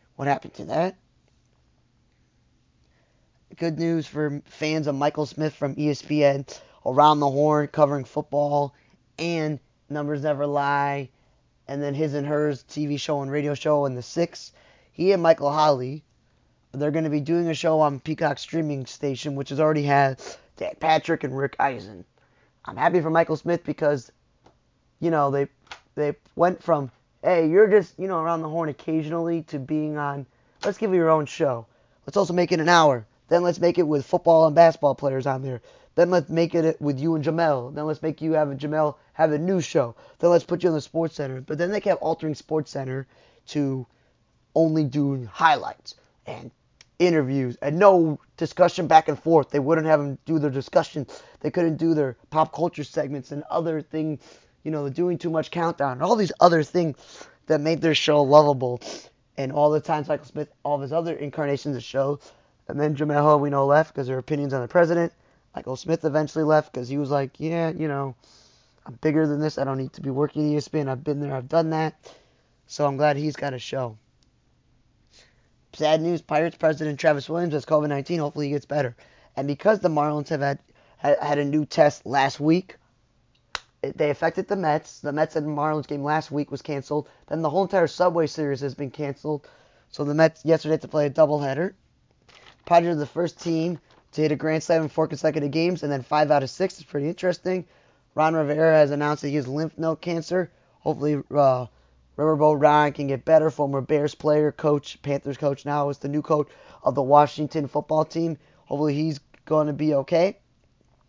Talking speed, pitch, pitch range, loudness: 195 wpm, 150 Hz, 140-160 Hz, -23 LUFS